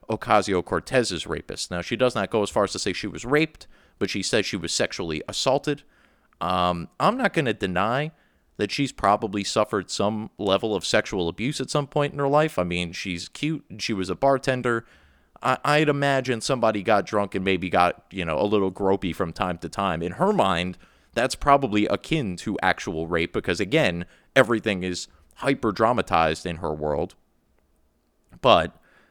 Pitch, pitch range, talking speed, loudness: 100 Hz, 90-130 Hz, 180 wpm, -24 LUFS